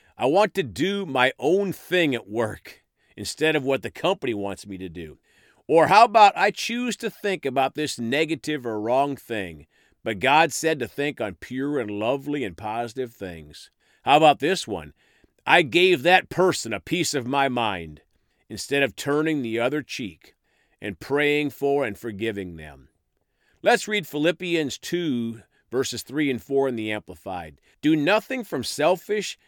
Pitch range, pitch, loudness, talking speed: 115-175 Hz, 140 Hz, -23 LUFS, 170 wpm